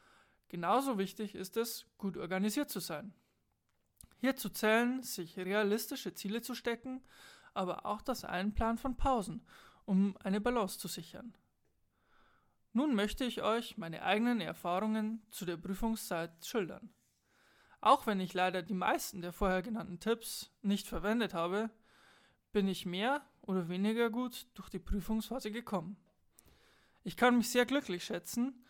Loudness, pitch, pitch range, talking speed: -36 LUFS, 215 Hz, 190-240 Hz, 140 wpm